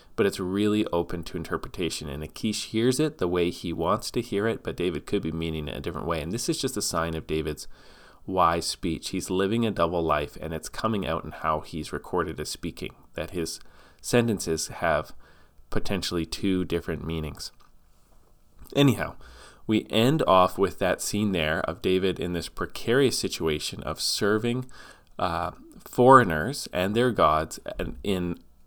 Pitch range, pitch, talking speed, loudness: 80-105 Hz, 85 Hz, 170 wpm, -26 LUFS